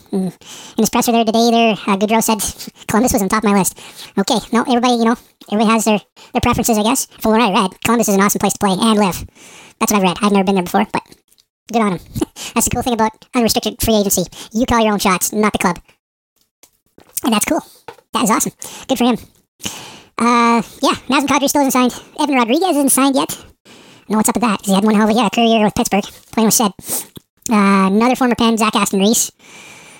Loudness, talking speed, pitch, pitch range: -15 LUFS, 230 wpm, 225 Hz, 205-240 Hz